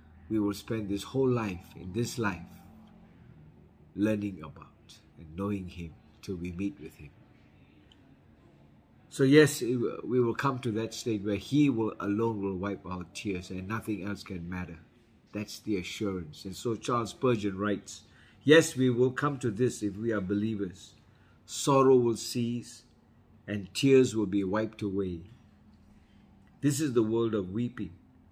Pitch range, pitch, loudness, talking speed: 95-120 Hz, 105 Hz, -30 LUFS, 155 wpm